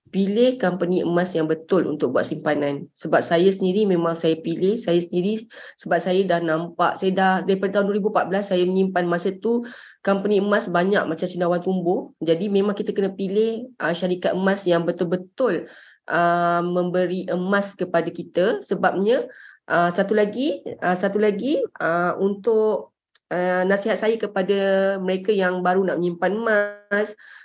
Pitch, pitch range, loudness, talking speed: 185 Hz, 175-205 Hz, -22 LUFS, 150 wpm